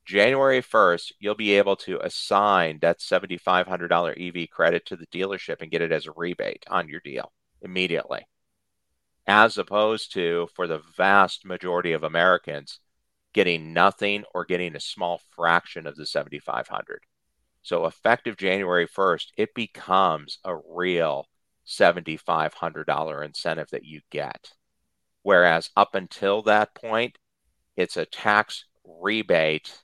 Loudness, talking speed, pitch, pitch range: -24 LUFS, 130 wpm, 90 Hz, 85-105 Hz